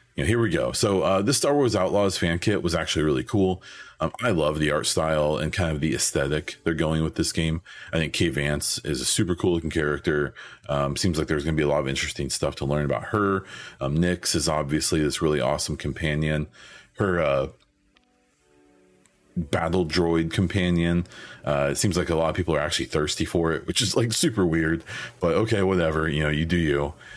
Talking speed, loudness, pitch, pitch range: 215 wpm, -24 LUFS, 80 Hz, 75-90 Hz